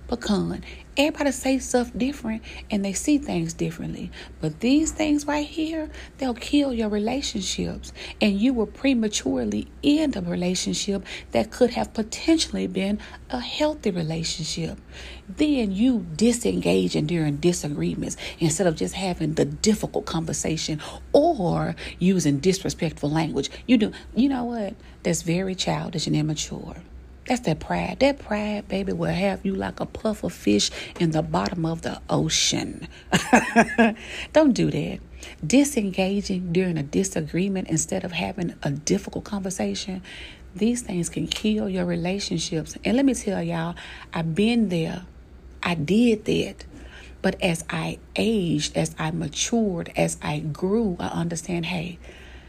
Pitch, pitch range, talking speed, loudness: 190 Hz, 165-225 Hz, 145 wpm, -24 LUFS